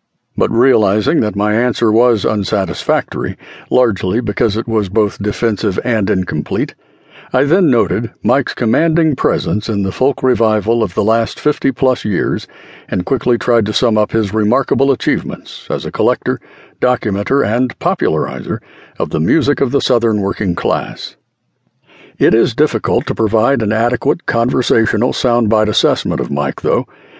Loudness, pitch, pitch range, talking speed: -15 LUFS, 115 Hz, 105-125 Hz, 150 wpm